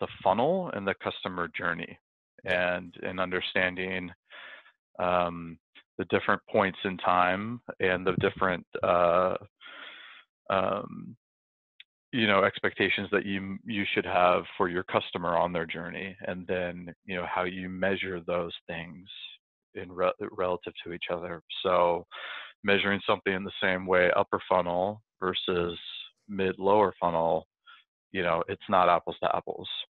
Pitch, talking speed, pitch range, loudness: 90 Hz, 135 wpm, 90-95 Hz, -29 LUFS